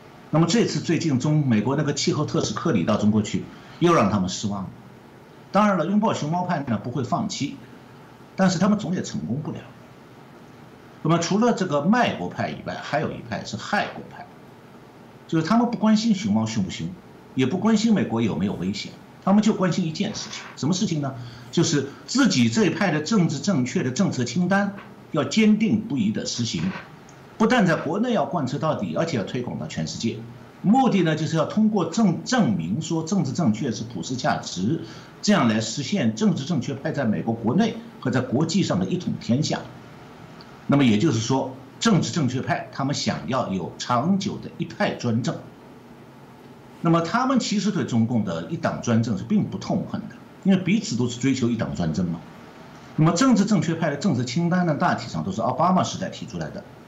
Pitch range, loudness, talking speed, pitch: 130-205 Hz, -23 LUFS, 295 characters per minute, 170 Hz